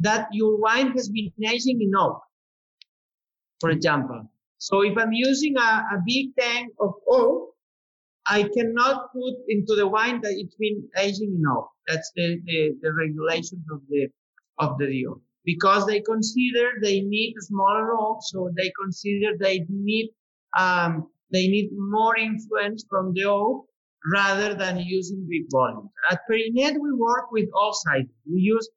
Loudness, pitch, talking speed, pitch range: -23 LUFS, 205 Hz, 155 wpm, 180-225 Hz